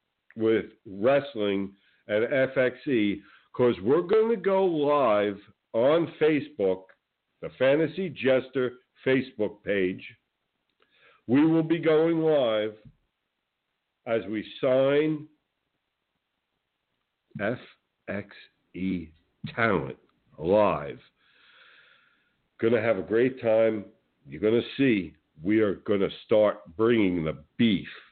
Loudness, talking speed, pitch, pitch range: -26 LUFS, 90 wpm, 115 Hz, 100-145 Hz